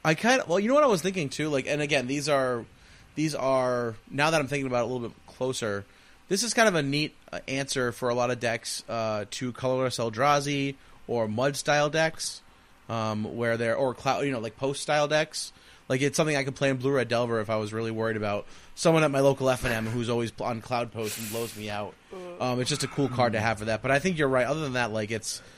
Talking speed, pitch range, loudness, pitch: 255 wpm, 115-145 Hz, -27 LUFS, 130 Hz